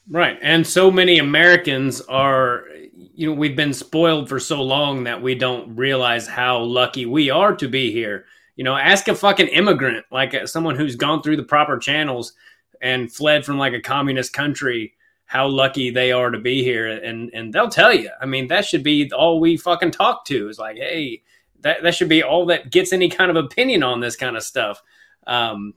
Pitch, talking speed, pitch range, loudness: 140 Hz, 205 wpm, 125-170 Hz, -18 LUFS